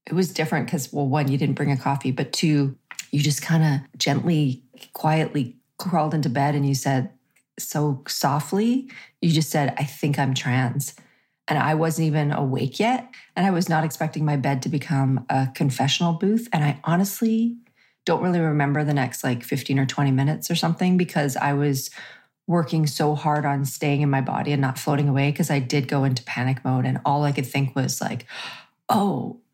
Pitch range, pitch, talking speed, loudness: 135-160 Hz, 145 Hz, 195 wpm, -23 LUFS